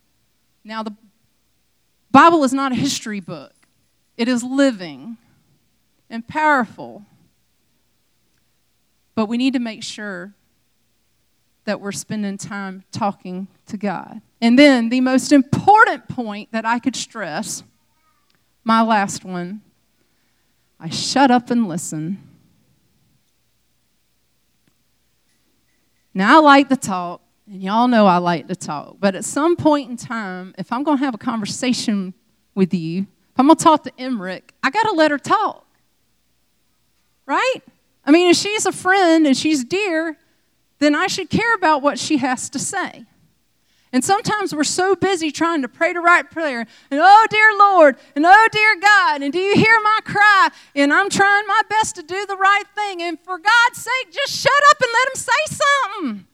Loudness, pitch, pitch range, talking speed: -16 LUFS, 270 Hz, 210-345 Hz, 160 wpm